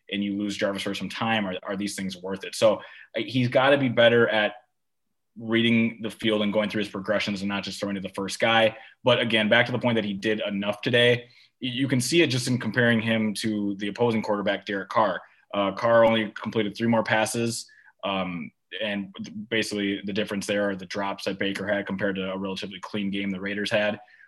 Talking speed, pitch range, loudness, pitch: 220 wpm, 100-115 Hz, -25 LUFS, 105 Hz